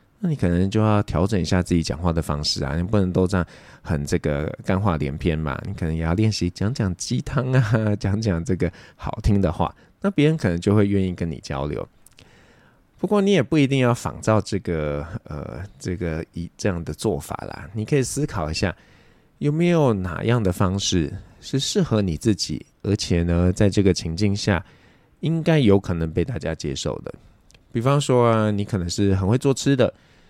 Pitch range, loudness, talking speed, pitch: 85-115 Hz, -22 LUFS, 280 characters per minute, 100 Hz